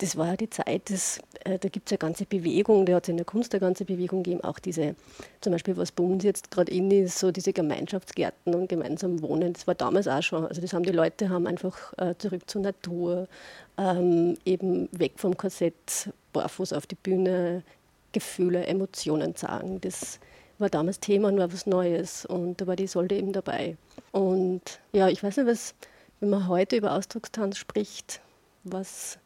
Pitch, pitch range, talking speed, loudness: 185 Hz, 175-195 Hz, 195 wpm, -28 LUFS